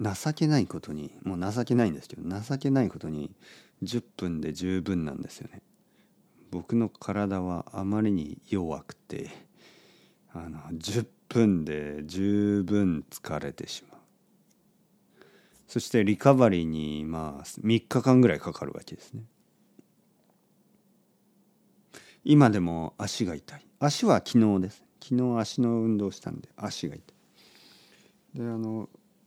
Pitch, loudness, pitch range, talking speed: 110 Hz, -28 LUFS, 90-135 Hz, 235 characters per minute